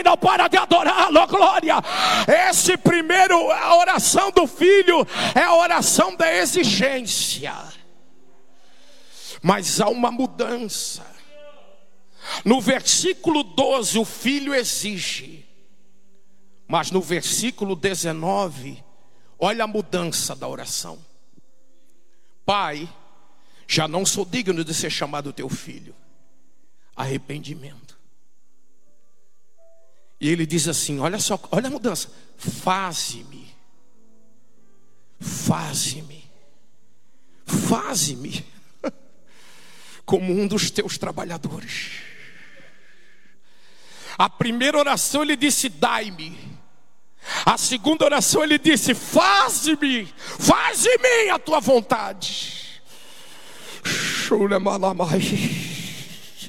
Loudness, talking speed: -20 LUFS, 85 wpm